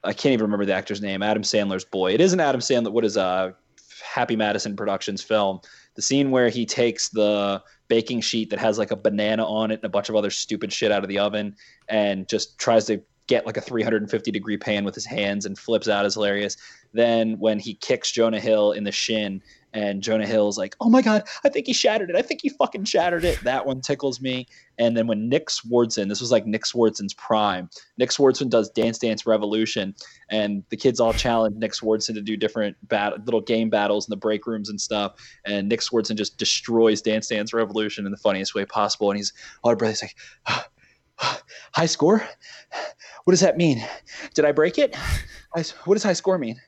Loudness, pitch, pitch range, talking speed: -23 LUFS, 110 Hz, 105-120 Hz, 215 wpm